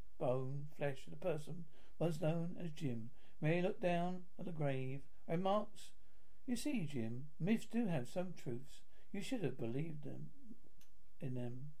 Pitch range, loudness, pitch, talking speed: 135-180 Hz, -43 LUFS, 160 Hz, 165 wpm